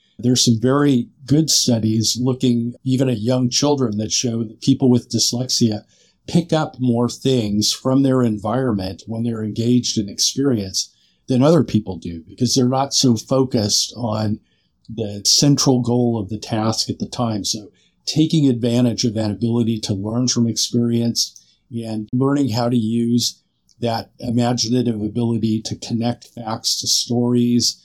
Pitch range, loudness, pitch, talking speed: 110-125 Hz, -18 LUFS, 120 Hz, 150 wpm